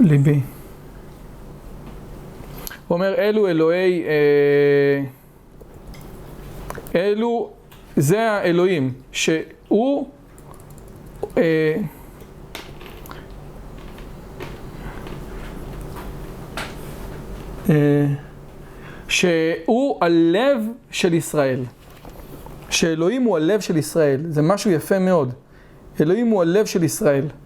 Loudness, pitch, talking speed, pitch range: -19 LUFS, 165 Hz, 60 wpm, 145-195 Hz